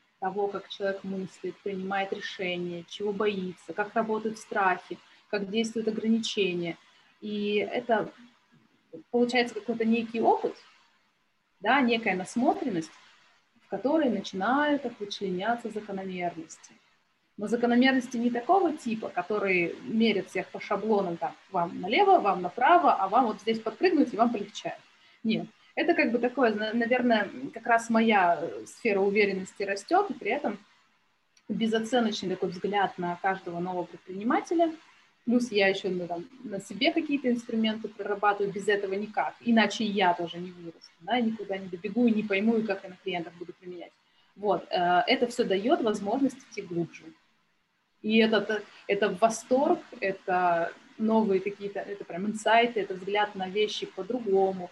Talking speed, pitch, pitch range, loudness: 140 wpm, 210 Hz, 190-235 Hz, -28 LUFS